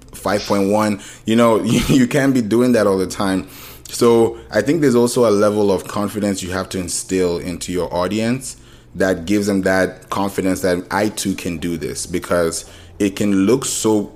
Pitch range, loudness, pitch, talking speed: 95-115 Hz, -18 LUFS, 105 Hz, 185 wpm